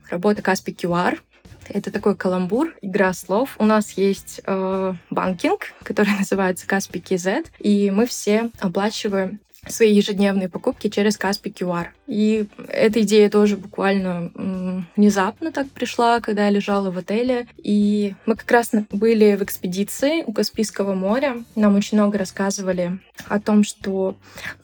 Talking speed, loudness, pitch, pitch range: 140 wpm, -20 LUFS, 205 Hz, 190-220 Hz